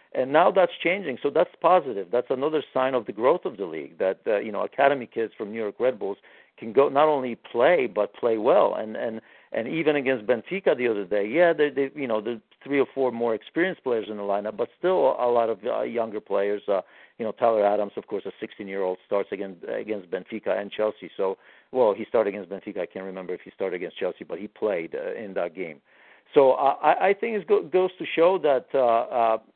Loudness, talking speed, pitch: -25 LUFS, 240 wpm, 130 Hz